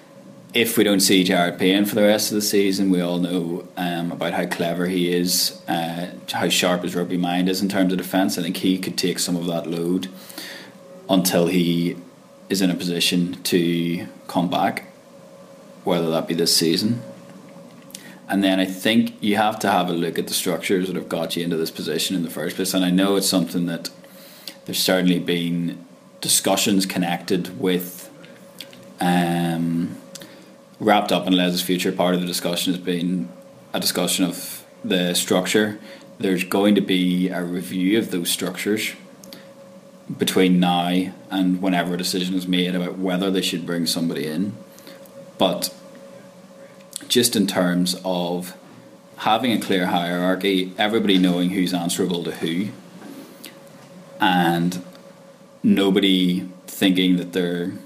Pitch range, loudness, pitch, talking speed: 90-95 Hz, -21 LUFS, 90 Hz, 160 wpm